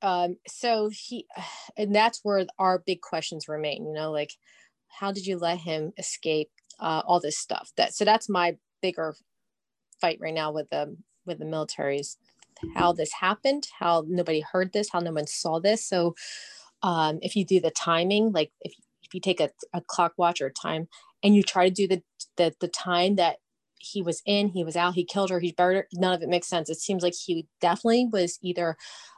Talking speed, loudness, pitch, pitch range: 210 wpm, -27 LUFS, 180 Hz, 165-195 Hz